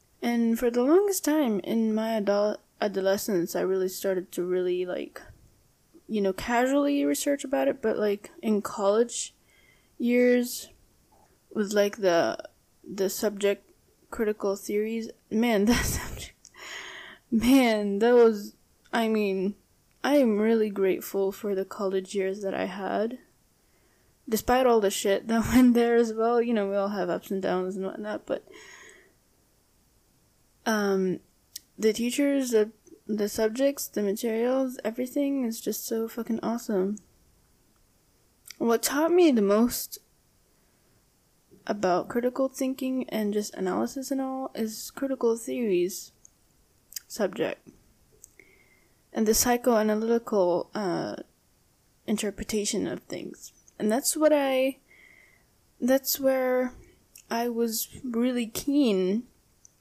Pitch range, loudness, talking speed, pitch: 200-250 Hz, -27 LUFS, 120 wpm, 225 Hz